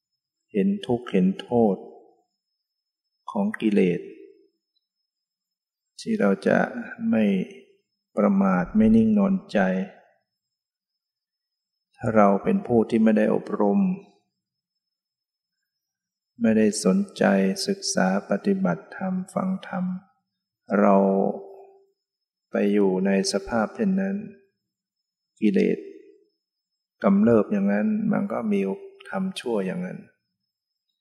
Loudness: -23 LUFS